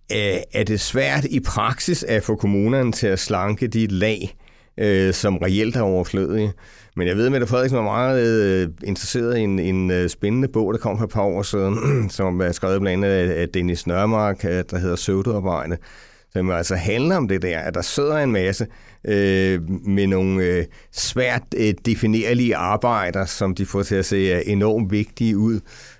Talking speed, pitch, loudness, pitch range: 165 wpm, 100 Hz, -21 LUFS, 95-115 Hz